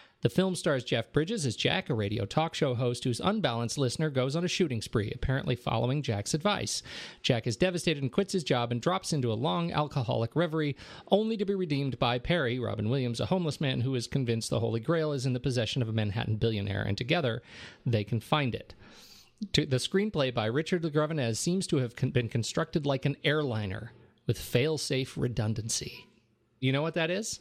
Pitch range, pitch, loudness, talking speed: 120-165 Hz, 135 Hz, -30 LUFS, 195 wpm